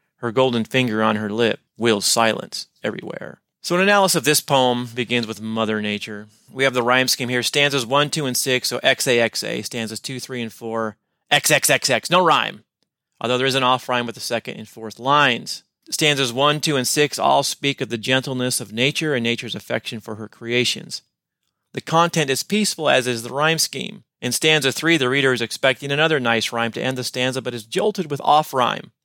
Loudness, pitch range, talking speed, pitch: -19 LUFS, 115-140 Hz, 205 wpm, 125 Hz